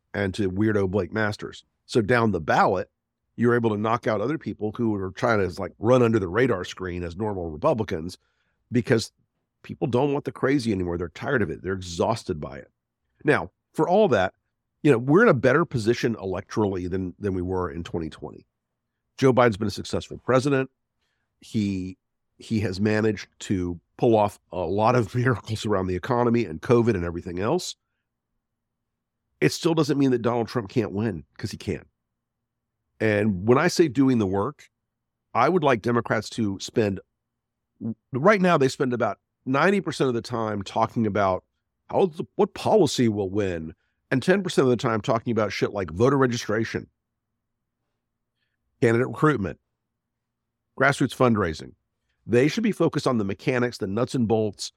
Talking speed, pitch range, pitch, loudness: 170 wpm, 95-125 Hz, 110 Hz, -24 LUFS